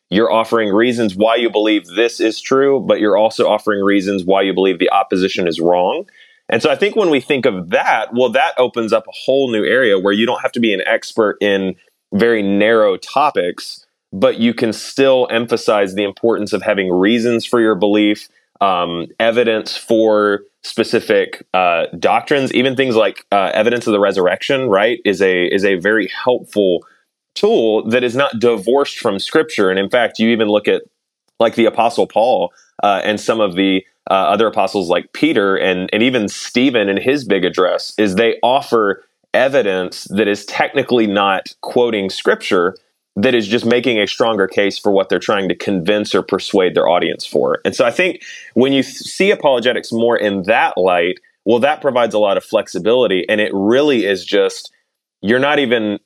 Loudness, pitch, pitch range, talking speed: -15 LUFS, 110 Hz, 100-125 Hz, 190 wpm